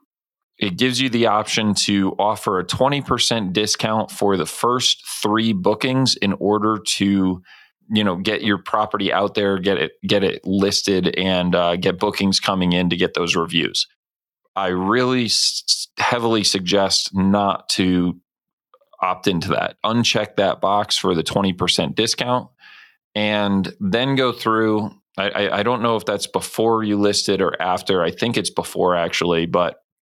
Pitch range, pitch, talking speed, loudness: 95-115 Hz, 100 Hz, 160 wpm, -19 LUFS